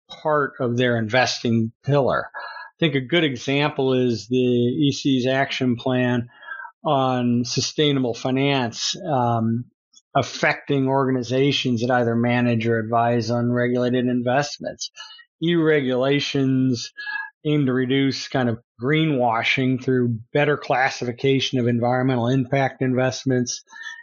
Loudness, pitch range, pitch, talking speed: -21 LUFS, 120-145 Hz, 130 Hz, 110 wpm